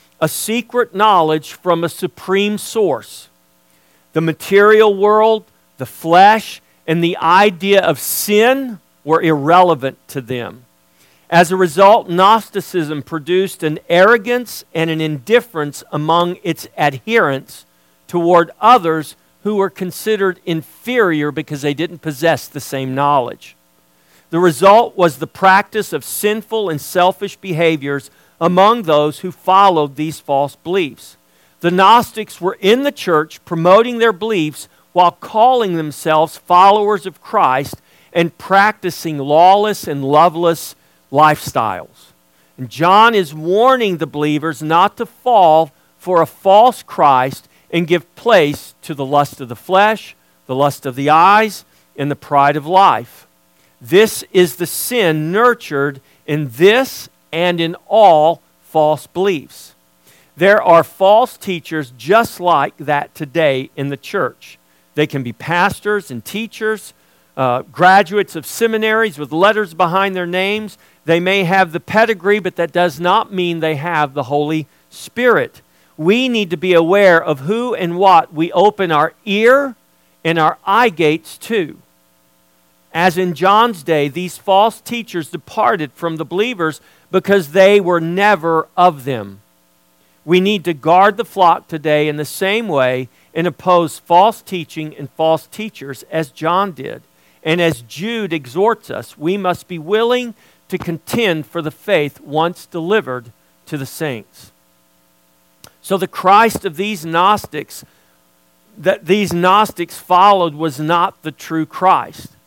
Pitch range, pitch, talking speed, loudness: 145-195 Hz, 170 Hz, 140 wpm, -14 LUFS